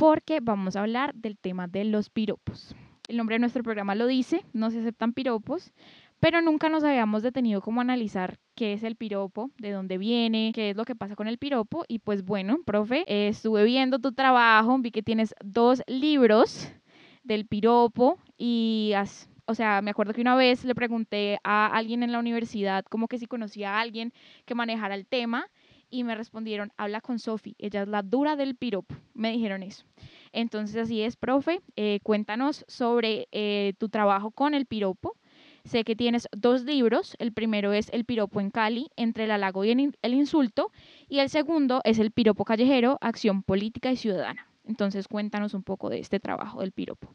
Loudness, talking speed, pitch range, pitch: -27 LUFS, 190 wpm, 210-250 Hz, 225 Hz